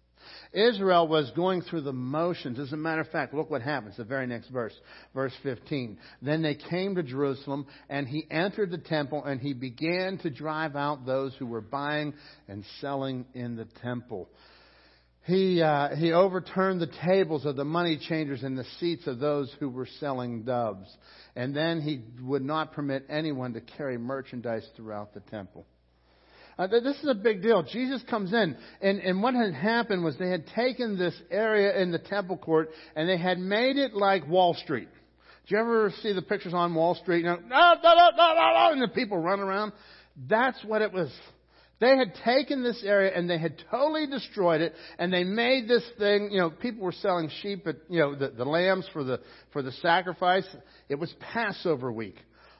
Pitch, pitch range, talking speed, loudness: 165 Hz, 140-195 Hz, 190 wpm, -27 LUFS